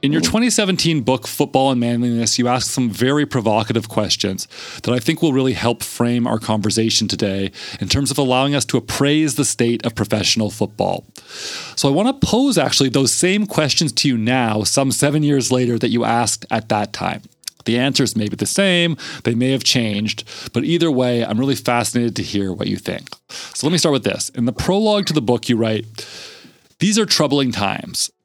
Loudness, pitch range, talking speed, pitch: -17 LUFS, 110-145 Hz, 205 wpm, 125 Hz